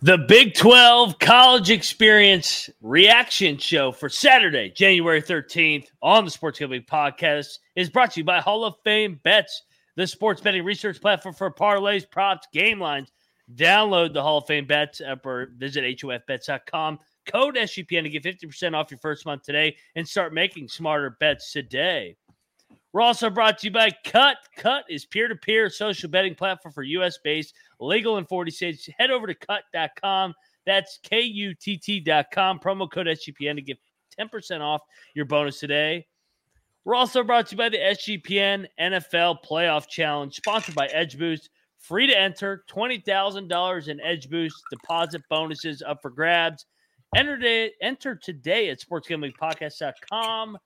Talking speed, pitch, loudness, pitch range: 150 wpm, 180 Hz, -20 LUFS, 155-210 Hz